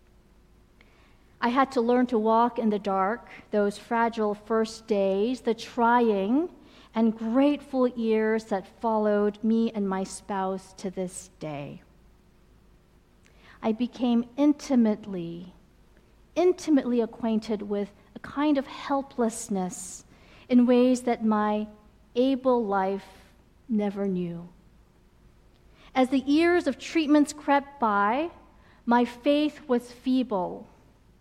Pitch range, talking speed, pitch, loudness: 205-260 Hz, 110 wpm, 230 Hz, -26 LUFS